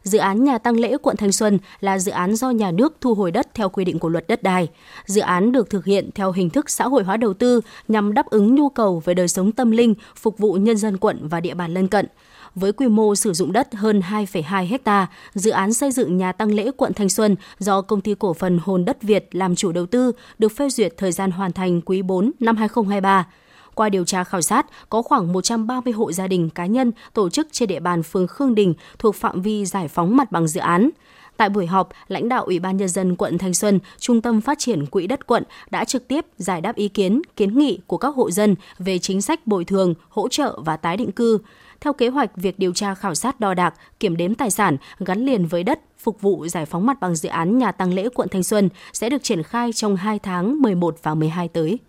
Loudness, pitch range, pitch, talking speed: -20 LUFS, 185-235 Hz, 205 Hz, 250 wpm